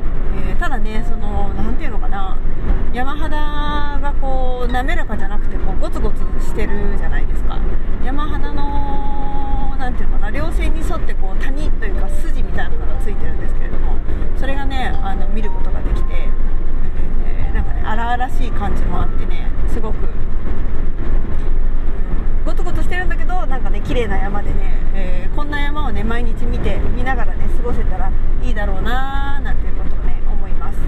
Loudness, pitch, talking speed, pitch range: -23 LUFS, 90 Hz, 325 characters per minute, 80-110 Hz